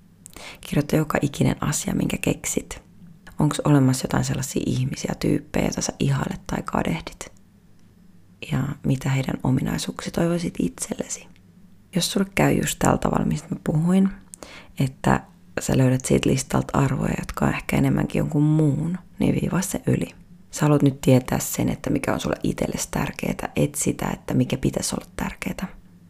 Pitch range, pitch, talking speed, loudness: 130-175 Hz, 145 Hz, 150 wpm, -23 LUFS